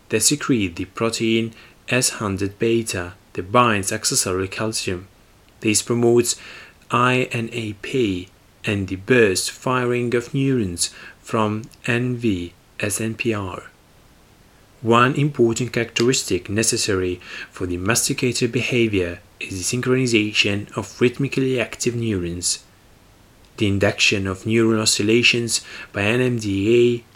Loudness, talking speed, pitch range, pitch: -20 LUFS, 100 wpm, 100-120 Hz, 115 Hz